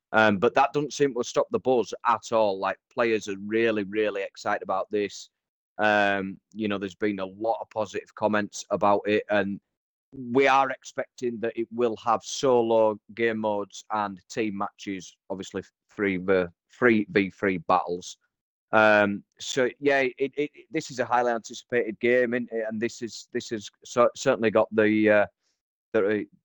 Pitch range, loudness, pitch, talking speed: 100-120 Hz, -26 LUFS, 110 Hz, 175 wpm